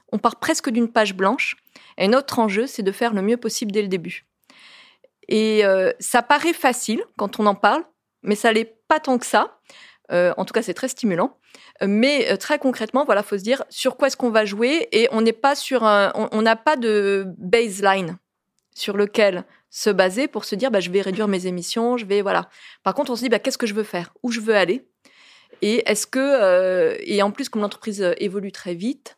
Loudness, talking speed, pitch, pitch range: -20 LUFS, 225 wpm, 225 Hz, 200-260 Hz